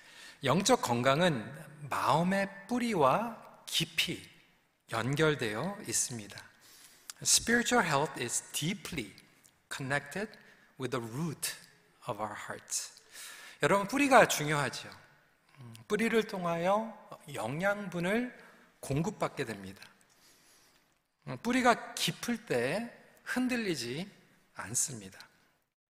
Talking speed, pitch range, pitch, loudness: 270 characters per minute, 145-230 Hz, 180 Hz, -31 LUFS